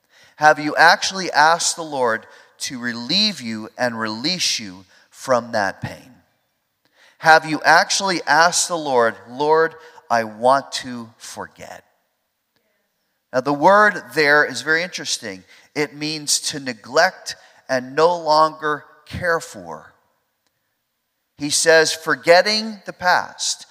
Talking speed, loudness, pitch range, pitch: 120 wpm, -18 LUFS, 125-165 Hz, 150 Hz